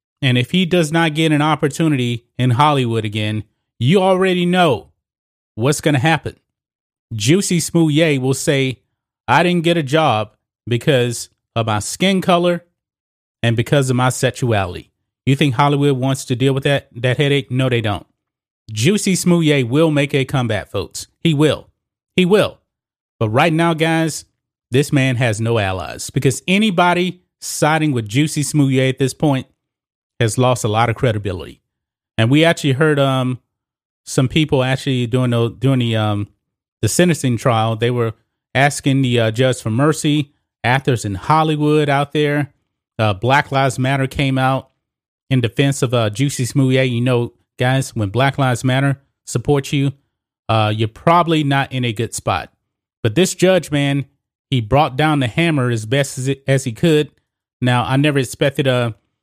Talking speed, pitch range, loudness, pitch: 165 wpm, 120-150 Hz, -17 LUFS, 135 Hz